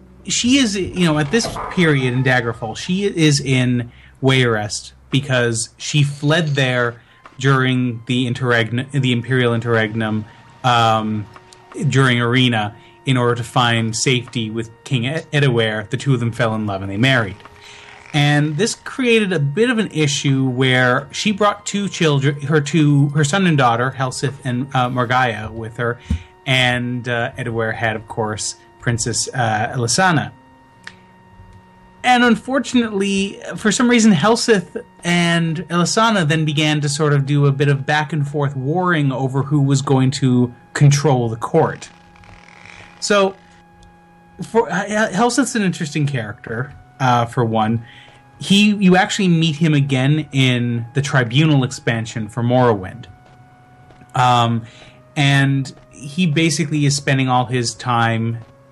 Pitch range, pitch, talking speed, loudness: 120-160 Hz, 130 Hz, 140 wpm, -17 LUFS